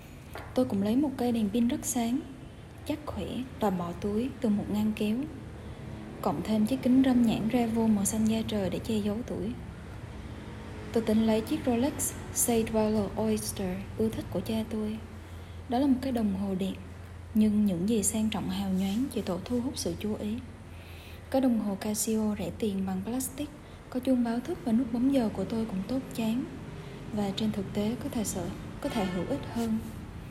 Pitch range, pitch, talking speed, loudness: 175-240 Hz, 215 Hz, 200 wpm, -30 LUFS